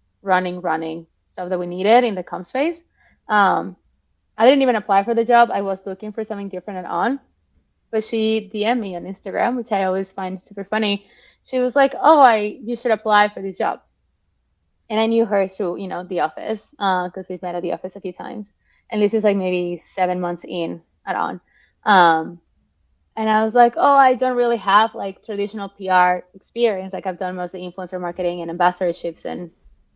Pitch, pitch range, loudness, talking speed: 195 Hz, 180-220 Hz, -20 LUFS, 205 wpm